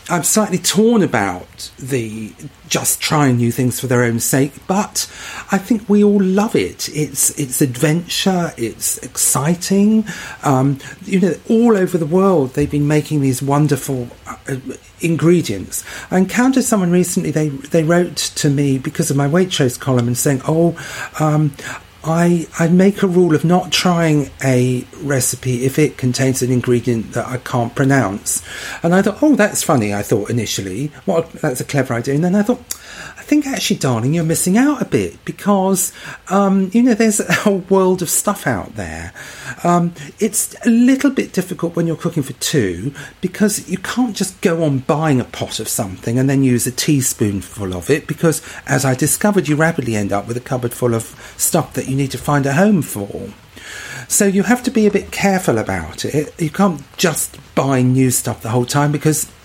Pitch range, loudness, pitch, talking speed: 130-185 Hz, -16 LUFS, 150 Hz, 190 wpm